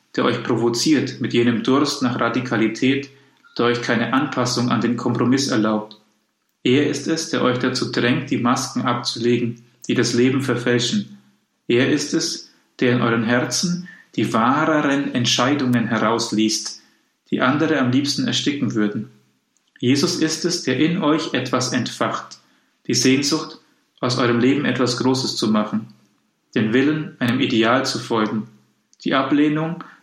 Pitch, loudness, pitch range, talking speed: 125 Hz, -20 LUFS, 115-135 Hz, 145 wpm